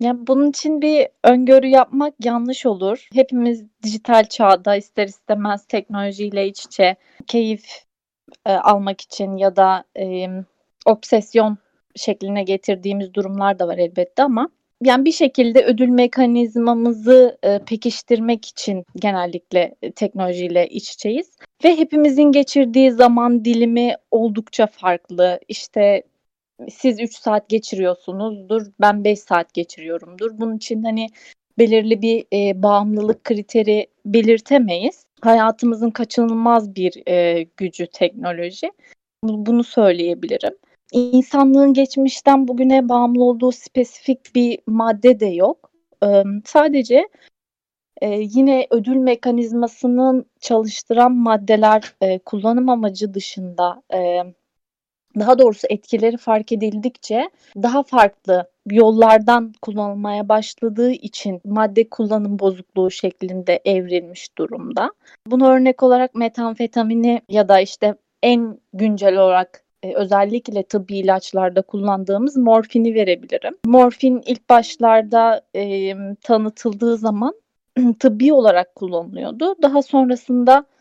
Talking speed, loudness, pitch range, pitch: 110 wpm, -17 LUFS, 200-250 Hz, 225 Hz